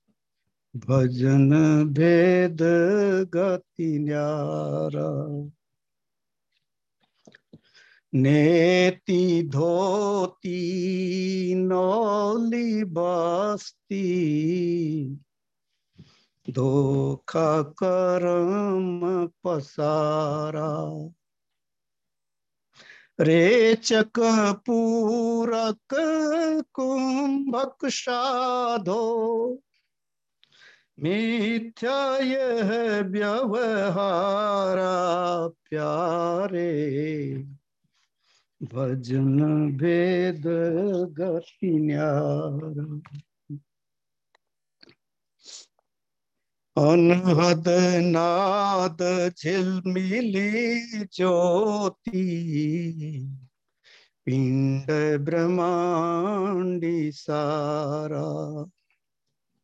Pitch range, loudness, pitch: 150-200 Hz, -24 LUFS, 175 Hz